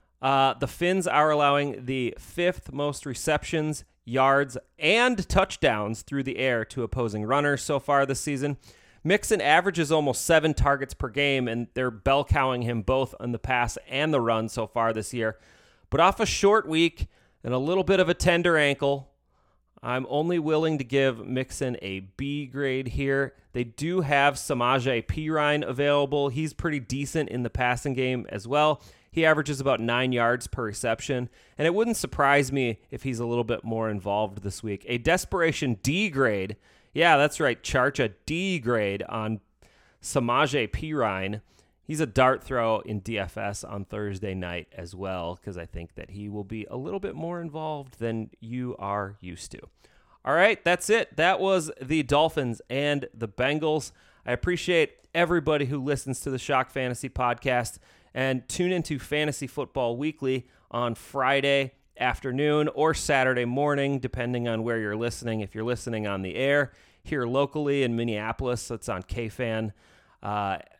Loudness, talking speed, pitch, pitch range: -26 LUFS, 165 wpm, 130 Hz, 115-145 Hz